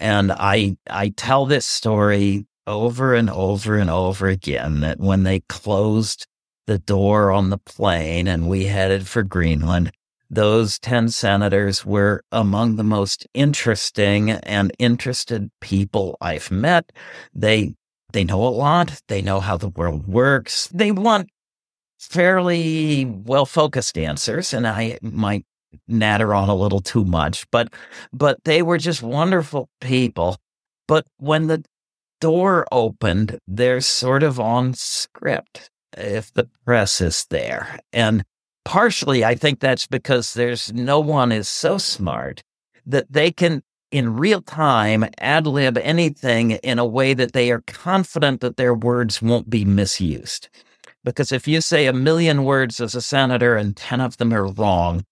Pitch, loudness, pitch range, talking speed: 115 Hz, -19 LUFS, 100-135 Hz, 150 wpm